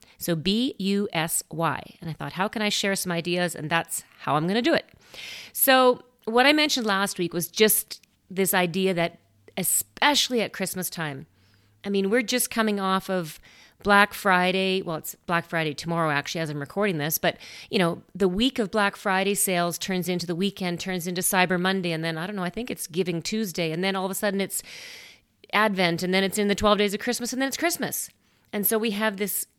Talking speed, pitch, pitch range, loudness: 220 wpm, 190 Hz, 175-210 Hz, -24 LUFS